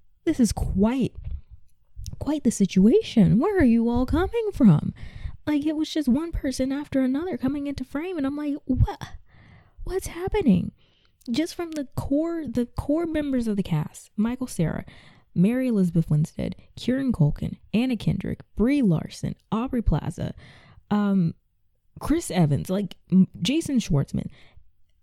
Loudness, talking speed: -24 LUFS, 140 wpm